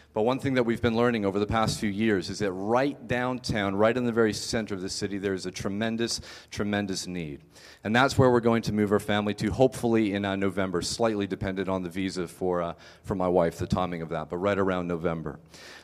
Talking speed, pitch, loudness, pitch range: 235 wpm, 100 Hz, -27 LUFS, 90-115 Hz